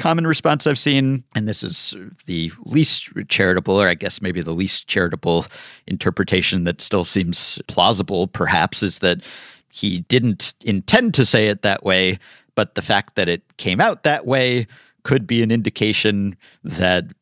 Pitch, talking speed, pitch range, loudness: 105 Hz, 165 wpm, 90-130 Hz, -19 LUFS